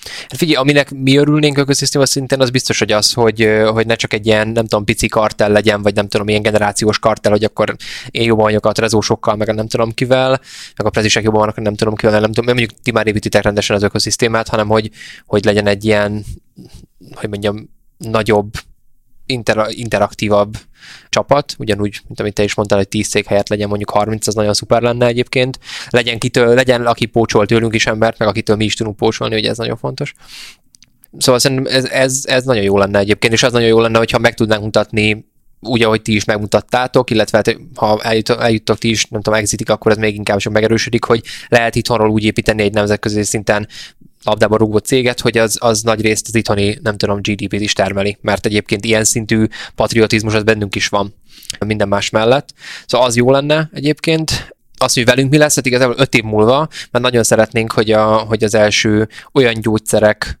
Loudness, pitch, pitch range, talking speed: -14 LUFS, 110 Hz, 105-120 Hz, 200 wpm